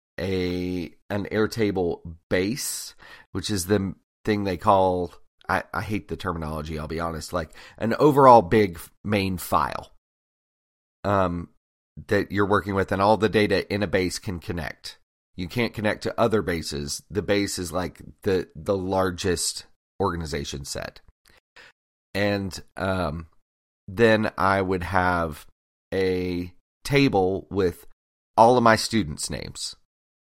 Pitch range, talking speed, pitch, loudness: 80-100 Hz, 135 wpm, 90 Hz, -24 LUFS